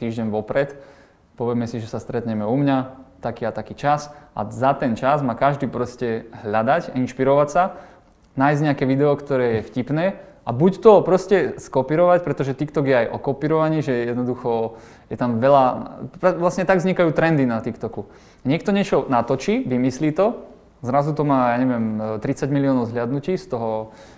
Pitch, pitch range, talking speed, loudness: 135 Hz, 120-155 Hz, 165 wpm, -20 LUFS